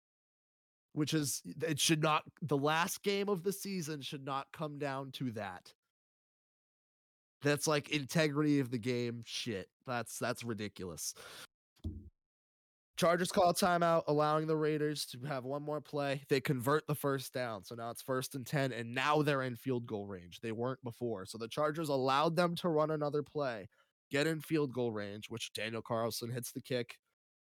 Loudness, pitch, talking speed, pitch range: -35 LUFS, 140 Hz, 175 wpm, 120-155 Hz